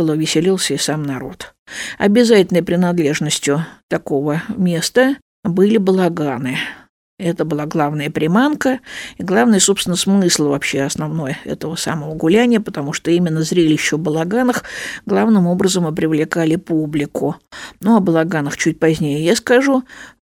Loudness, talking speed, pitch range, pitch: -16 LUFS, 120 wpm, 150-195 Hz, 165 Hz